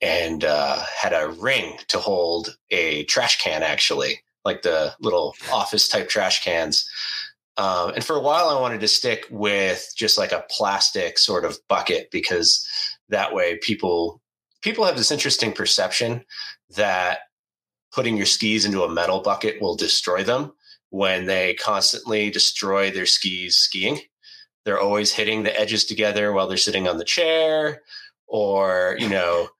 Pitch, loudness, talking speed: 110 Hz, -20 LUFS, 155 wpm